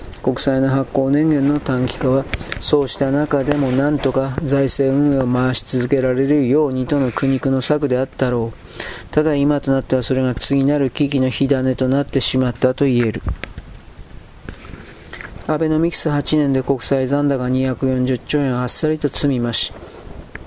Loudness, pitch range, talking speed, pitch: -18 LUFS, 130-145 Hz, 310 characters per minute, 135 Hz